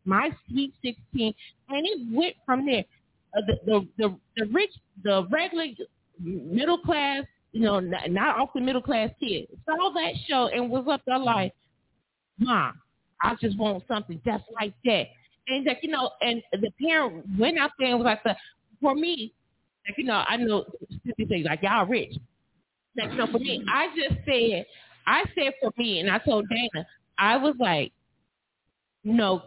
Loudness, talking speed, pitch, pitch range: -26 LUFS, 175 wpm, 240 Hz, 215-280 Hz